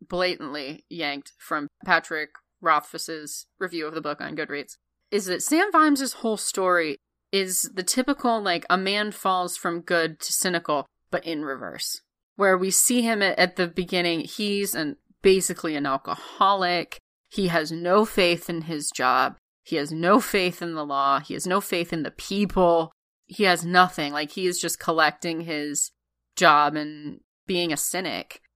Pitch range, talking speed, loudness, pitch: 155-195 Hz, 165 wpm, -24 LUFS, 175 Hz